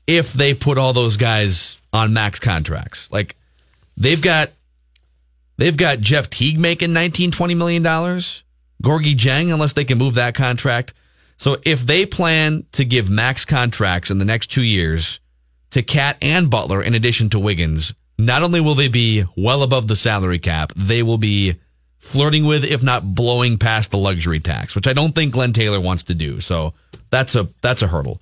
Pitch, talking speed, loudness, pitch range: 115 Hz, 185 wpm, -17 LUFS, 95-140 Hz